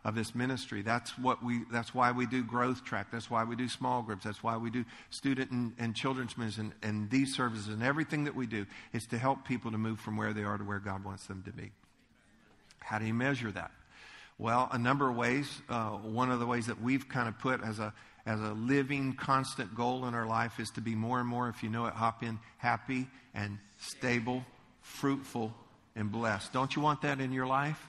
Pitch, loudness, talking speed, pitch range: 120 Hz, -34 LUFS, 230 wpm, 110-130 Hz